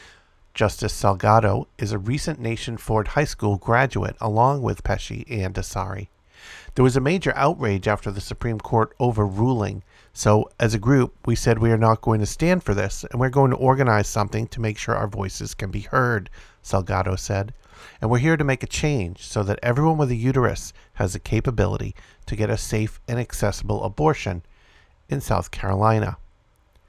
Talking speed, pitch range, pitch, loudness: 180 wpm, 100-125 Hz, 110 Hz, -22 LUFS